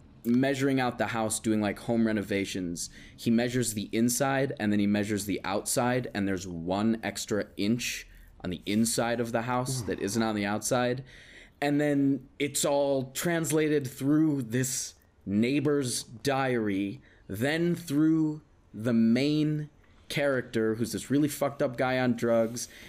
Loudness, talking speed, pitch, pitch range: -28 LUFS, 145 wpm, 120 Hz, 105-140 Hz